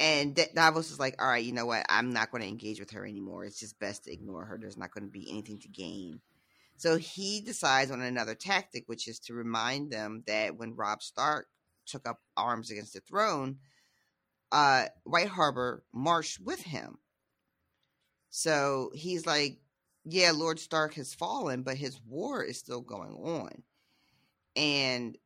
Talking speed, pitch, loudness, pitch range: 175 wpm, 130 Hz, -31 LUFS, 110-155 Hz